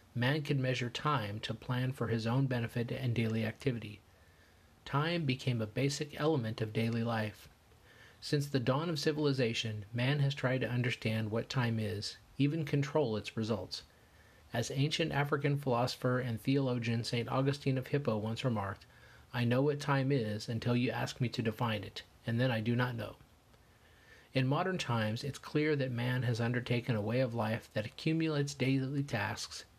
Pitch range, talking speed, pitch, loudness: 110-135 Hz, 170 wpm, 120 Hz, -34 LUFS